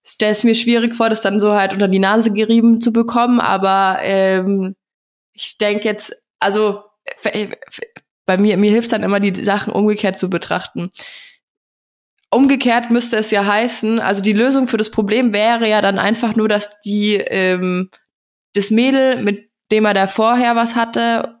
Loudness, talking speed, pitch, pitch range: -15 LUFS, 175 wpm, 215 Hz, 200-230 Hz